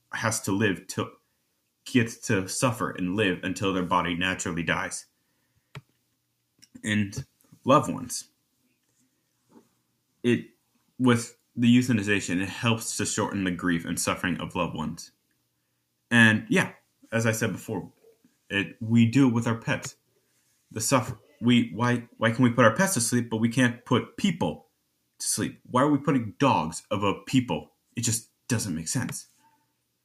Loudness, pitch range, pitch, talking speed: -26 LUFS, 90-120 Hz, 115 Hz, 150 wpm